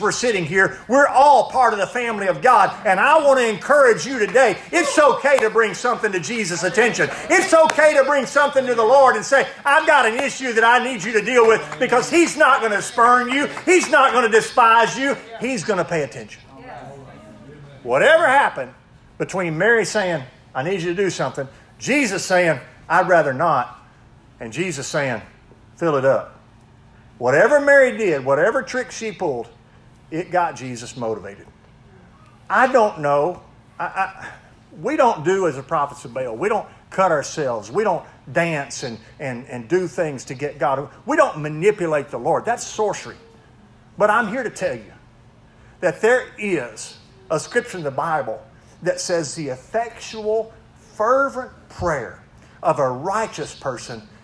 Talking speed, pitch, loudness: 175 wpm, 185 Hz, -18 LUFS